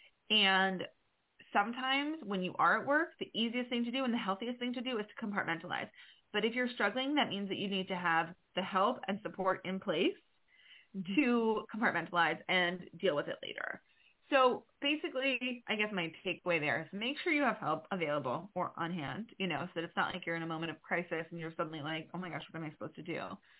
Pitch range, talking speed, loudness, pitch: 170-245 Hz, 225 wpm, -35 LUFS, 195 Hz